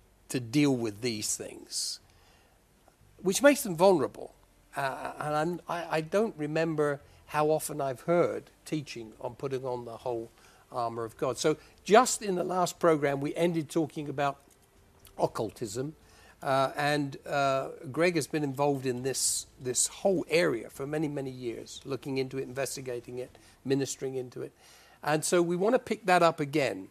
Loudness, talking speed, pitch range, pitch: -30 LUFS, 165 wpm, 130-165 Hz, 145 Hz